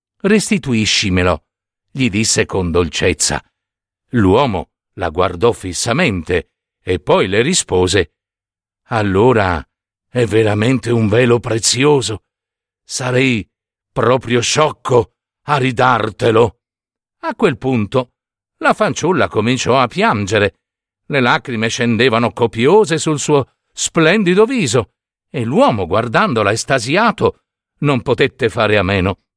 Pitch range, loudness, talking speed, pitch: 100-130 Hz, -15 LUFS, 100 wpm, 115 Hz